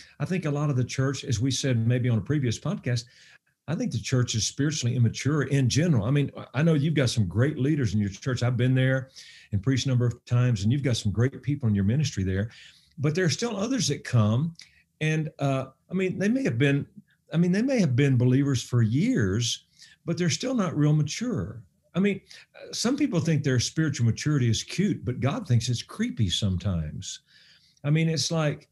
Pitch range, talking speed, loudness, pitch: 120-155 Hz, 220 wpm, -26 LUFS, 135 Hz